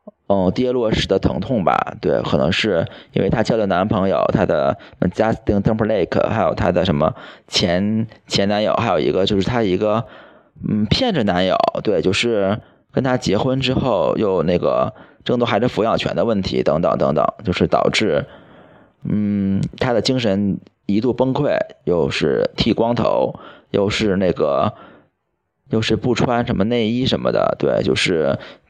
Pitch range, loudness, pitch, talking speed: 100-120 Hz, -18 LUFS, 110 Hz, 255 characters per minute